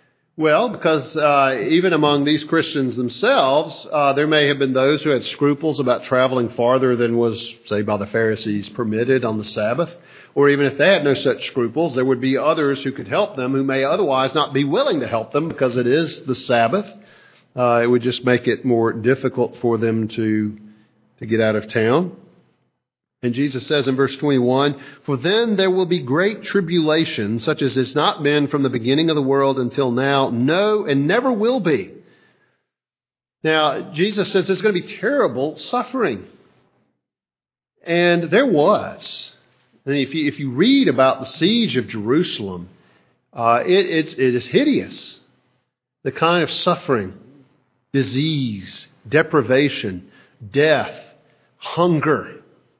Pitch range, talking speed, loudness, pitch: 125-155 Hz, 165 wpm, -18 LUFS, 140 Hz